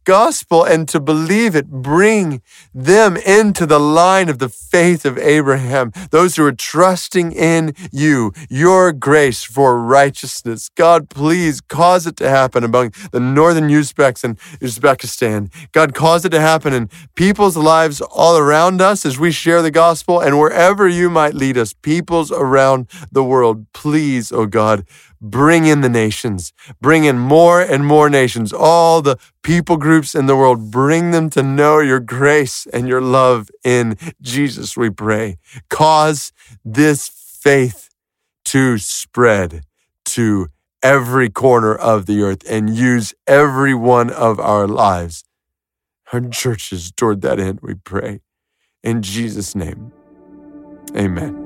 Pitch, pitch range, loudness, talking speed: 140 Hz, 120-160 Hz, -13 LUFS, 145 wpm